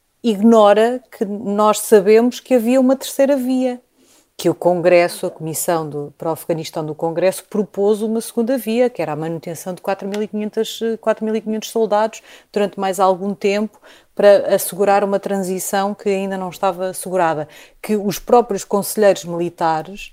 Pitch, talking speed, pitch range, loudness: 200 Hz, 145 wpm, 180-220 Hz, -17 LUFS